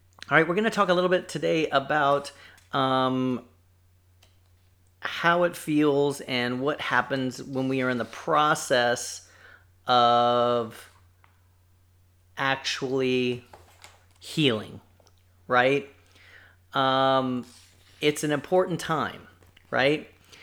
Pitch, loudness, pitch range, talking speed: 125 Hz, -25 LUFS, 90-140 Hz, 100 wpm